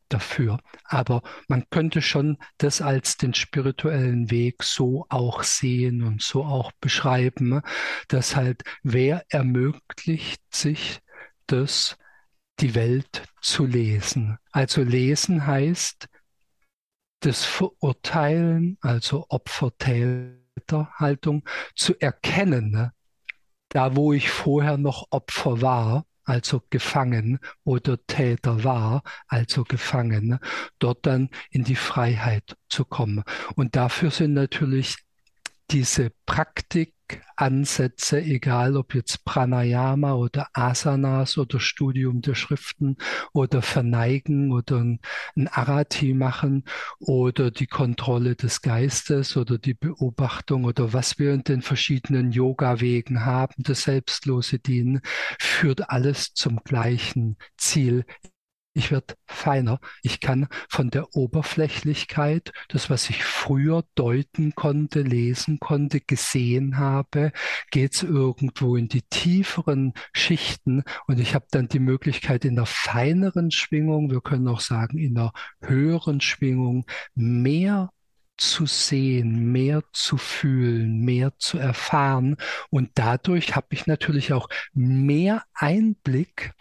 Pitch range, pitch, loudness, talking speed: 125-145 Hz, 135 Hz, -23 LUFS, 115 wpm